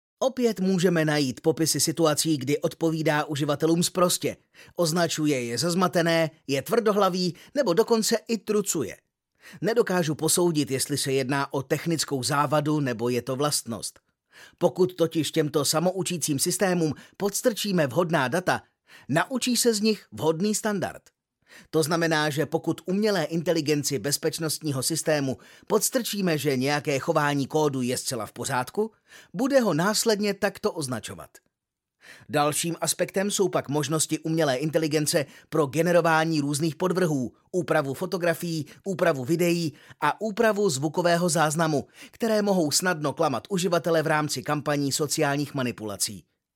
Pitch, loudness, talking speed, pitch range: 160 Hz, -25 LUFS, 125 wpm, 145-185 Hz